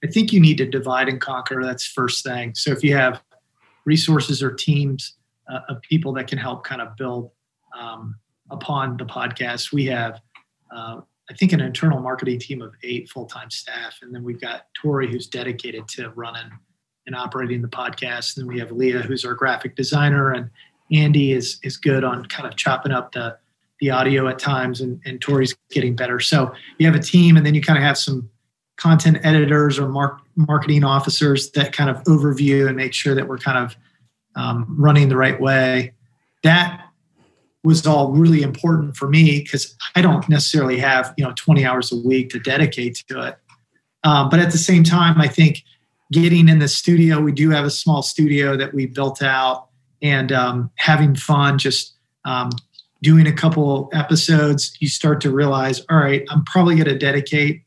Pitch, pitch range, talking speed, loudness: 135 Hz, 125-150 Hz, 195 wpm, -17 LUFS